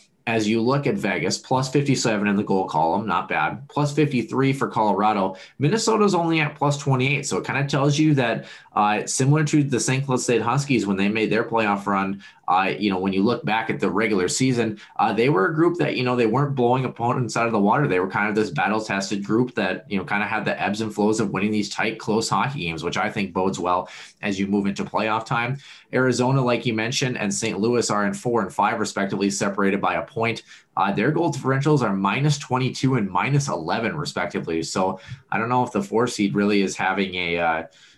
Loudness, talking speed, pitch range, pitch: -22 LUFS, 230 wpm, 100-130 Hz, 115 Hz